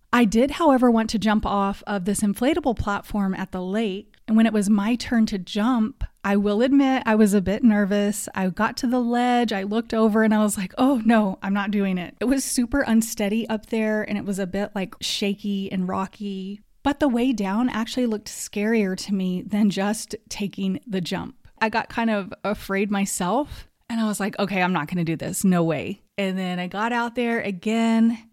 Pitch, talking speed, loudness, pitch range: 210 Hz, 215 wpm, -23 LUFS, 195-230 Hz